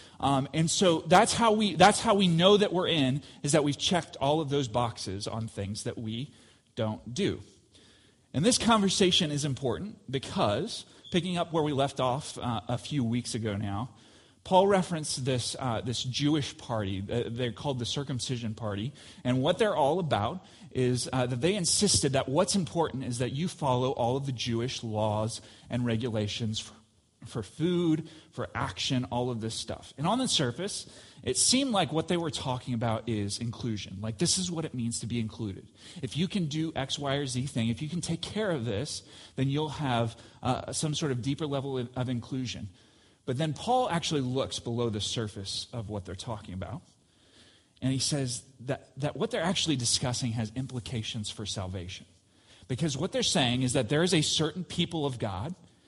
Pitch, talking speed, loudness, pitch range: 130 Hz, 195 wpm, -29 LUFS, 115-155 Hz